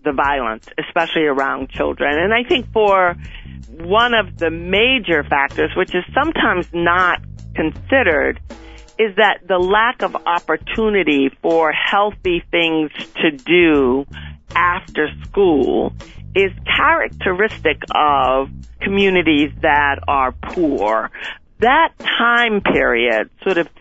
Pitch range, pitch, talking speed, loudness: 145-215 Hz, 175 Hz, 110 wpm, -16 LUFS